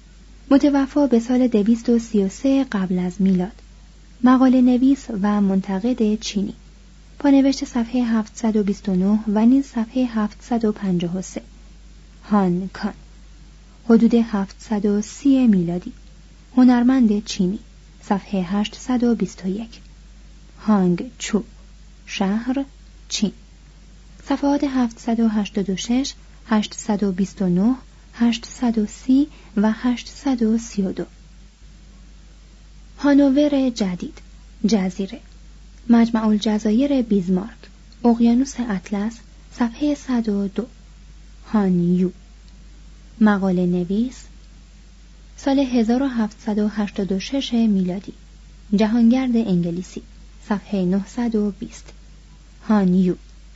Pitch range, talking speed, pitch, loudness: 195-245 Hz, 70 wpm, 215 Hz, -20 LUFS